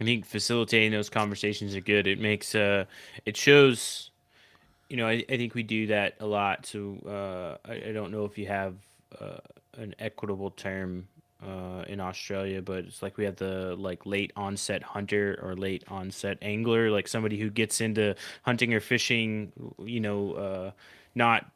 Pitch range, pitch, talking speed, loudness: 95-110 Hz, 105 Hz, 180 wpm, -29 LUFS